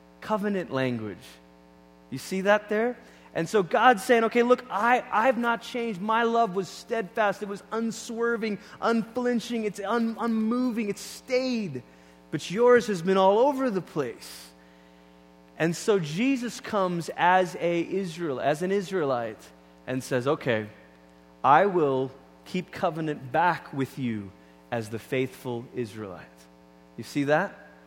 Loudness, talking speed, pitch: -26 LUFS, 140 wpm, 180 Hz